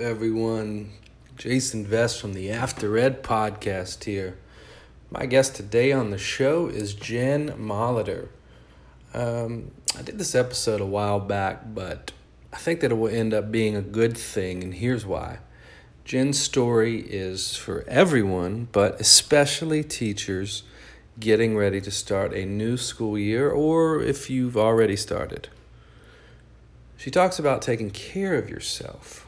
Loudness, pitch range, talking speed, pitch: -24 LUFS, 100-125 Hz, 140 wpm, 110 Hz